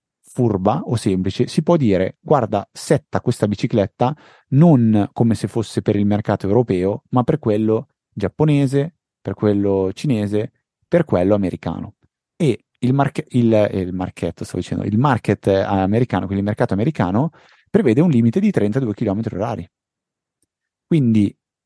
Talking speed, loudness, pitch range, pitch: 145 wpm, -18 LUFS, 100-130 Hz, 110 Hz